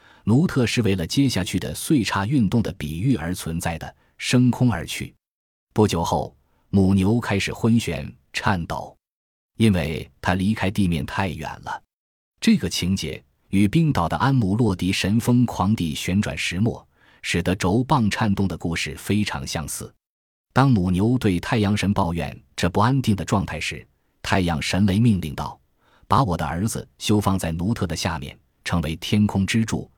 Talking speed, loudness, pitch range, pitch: 240 characters per minute, -22 LUFS, 85-115 Hz, 100 Hz